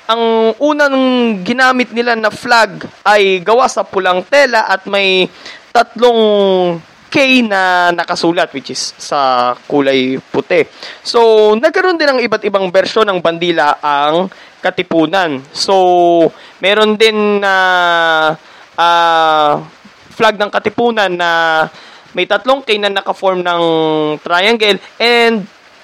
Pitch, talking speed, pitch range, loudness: 195 Hz, 120 wpm, 170-230 Hz, -11 LUFS